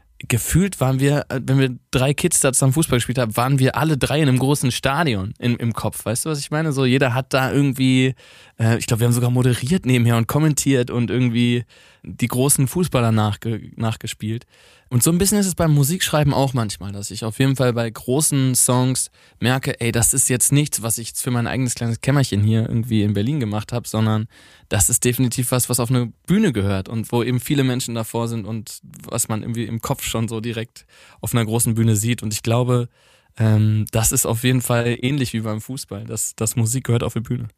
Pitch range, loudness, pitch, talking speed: 115-135 Hz, -19 LUFS, 120 Hz, 220 wpm